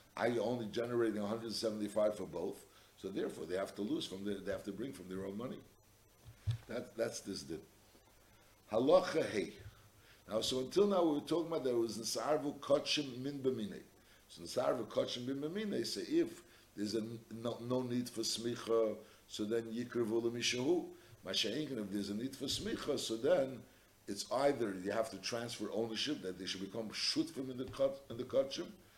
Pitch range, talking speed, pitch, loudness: 105-135 Hz, 180 wpm, 115 Hz, -38 LUFS